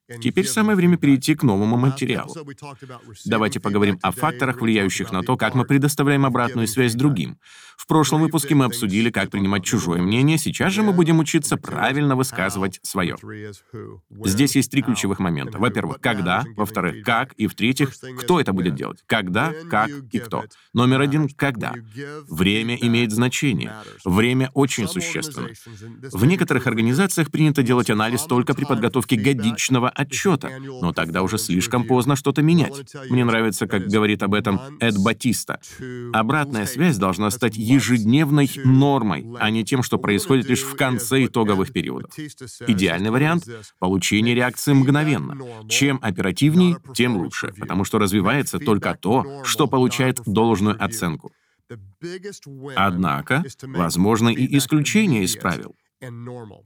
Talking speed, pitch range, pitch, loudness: 140 wpm, 110-140 Hz, 125 Hz, -20 LUFS